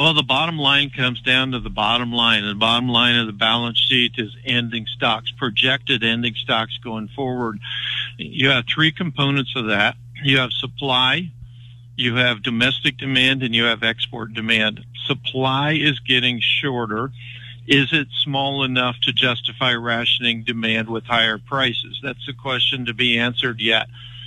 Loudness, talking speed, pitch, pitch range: -18 LUFS, 160 wpm, 120 Hz, 115-130 Hz